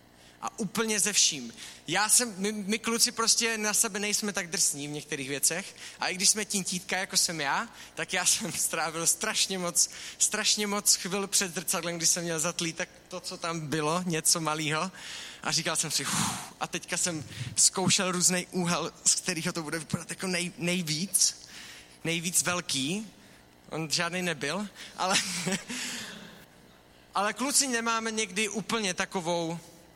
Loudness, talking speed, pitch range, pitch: -27 LUFS, 160 wpm, 160-205 Hz, 180 Hz